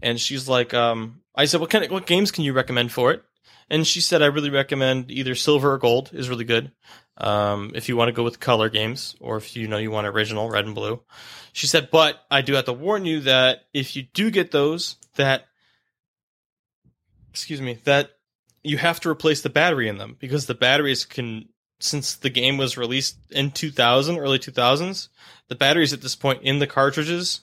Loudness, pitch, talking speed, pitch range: -21 LUFS, 135 Hz, 210 wpm, 120-150 Hz